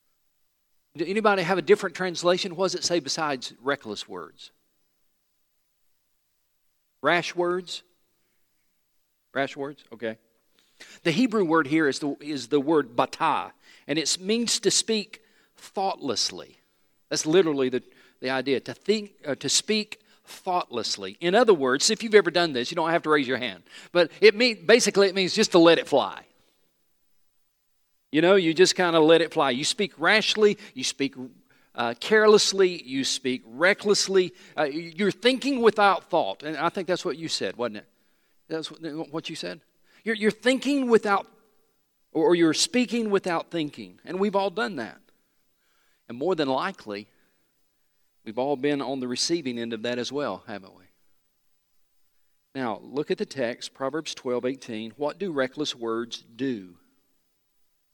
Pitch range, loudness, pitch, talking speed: 135-200 Hz, -24 LUFS, 170 Hz, 155 wpm